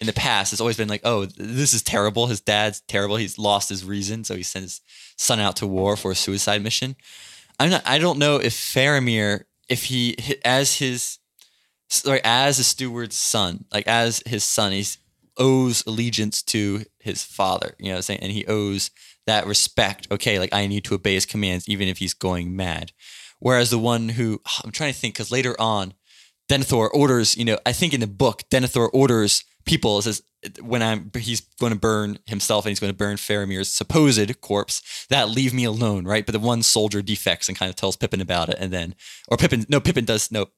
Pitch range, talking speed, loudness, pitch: 100-120 Hz, 215 wpm, -21 LUFS, 110 Hz